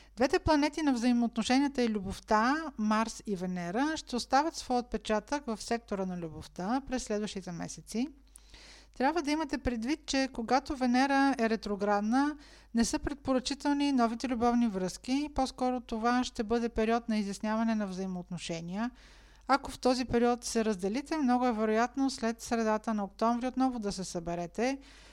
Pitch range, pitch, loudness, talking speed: 215-270 Hz, 240 Hz, -31 LUFS, 145 wpm